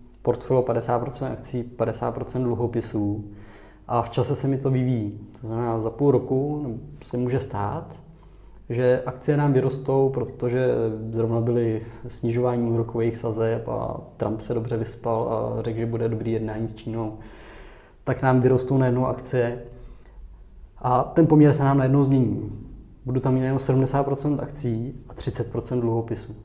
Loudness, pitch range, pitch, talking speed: -24 LUFS, 115-130 Hz, 120 Hz, 145 wpm